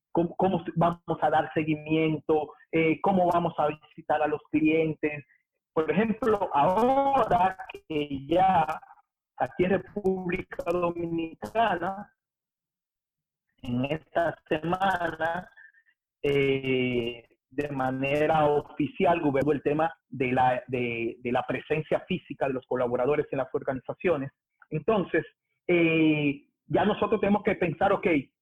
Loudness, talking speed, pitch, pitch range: -27 LUFS, 115 wpm, 160 Hz, 145-180 Hz